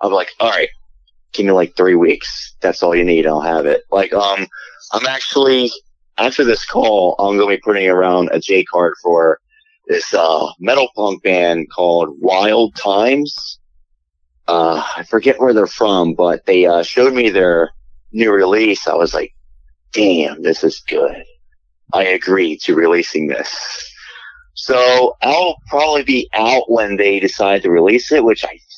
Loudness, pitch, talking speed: -14 LUFS, 100 Hz, 165 wpm